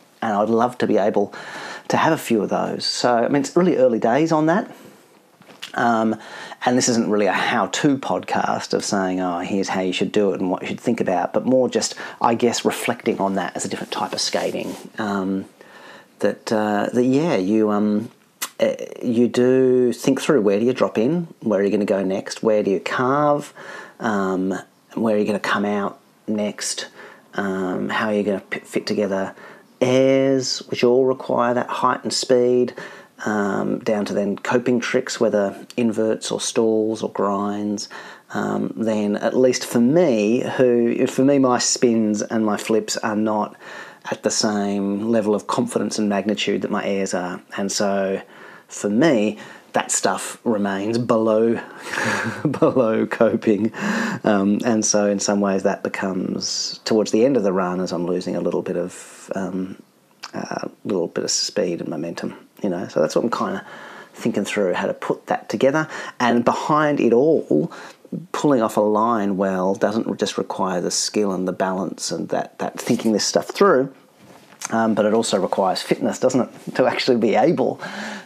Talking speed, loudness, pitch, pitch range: 185 wpm, -20 LUFS, 110 Hz, 100-125 Hz